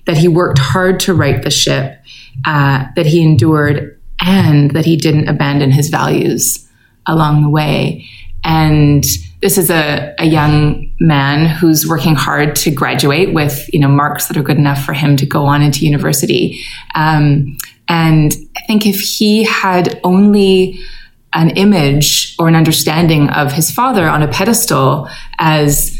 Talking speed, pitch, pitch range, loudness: 160 wpm, 150 Hz, 145-165 Hz, -11 LUFS